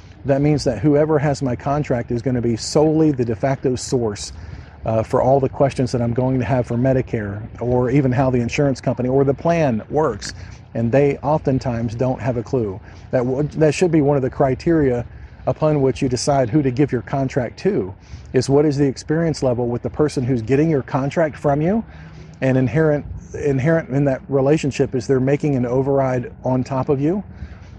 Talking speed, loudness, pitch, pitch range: 205 wpm, -19 LUFS, 130 Hz, 120-145 Hz